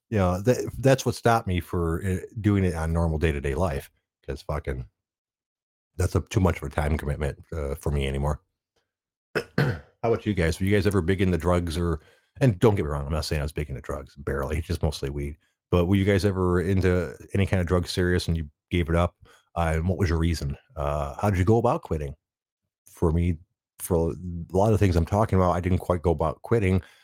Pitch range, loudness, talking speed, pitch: 80-100 Hz, -26 LUFS, 235 wpm, 90 Hz